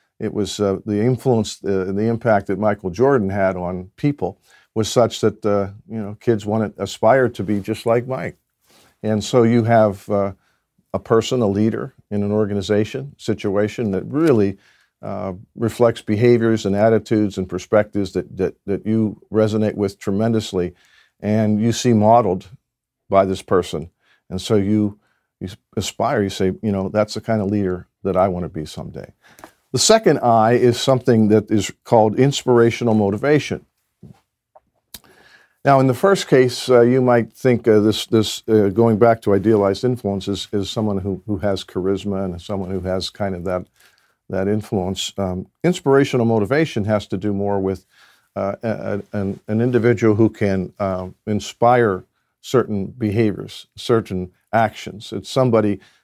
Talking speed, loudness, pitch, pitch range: 160 wpm, -19 LUFS, 105 Hz, 100-115 Hz